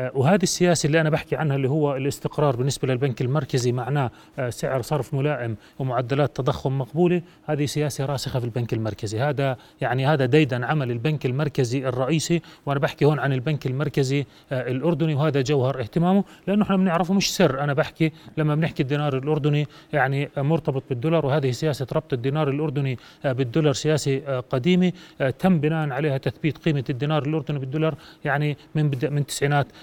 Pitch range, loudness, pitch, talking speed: 135-155 Hz, -23 LUFS, 145 Hz, 155 wpm